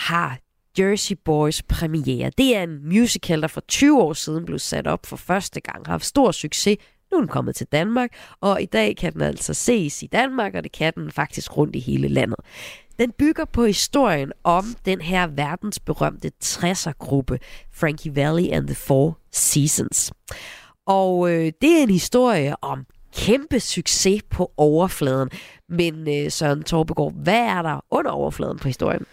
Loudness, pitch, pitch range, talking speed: -21 LUFS, 170 Hz, 150-205 Hz, 175 wpm